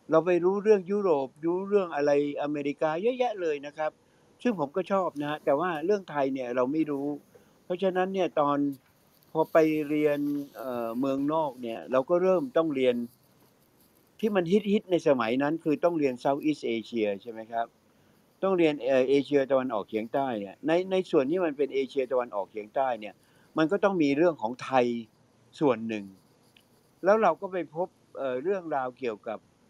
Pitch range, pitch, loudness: 130-175 Hz, 145 Hz, -28 LUFS